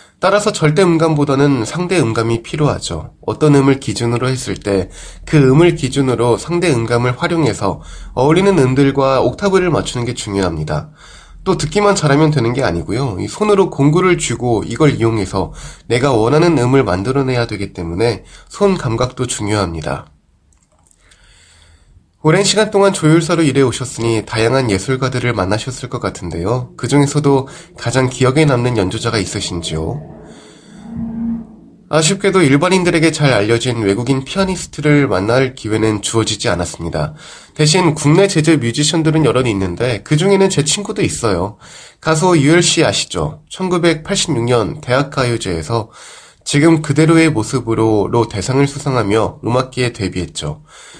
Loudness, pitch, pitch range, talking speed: -14 LUFS, 130 Hz, 110-160 Hz, 330 characters per minute